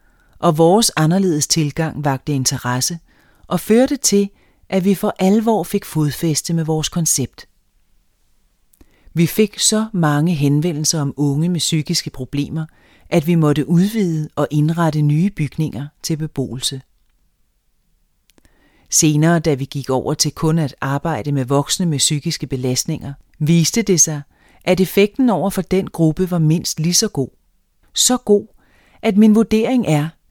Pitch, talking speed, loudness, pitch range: 160 Hz, 145 wpm, -17 LUFS, 150-185 Hz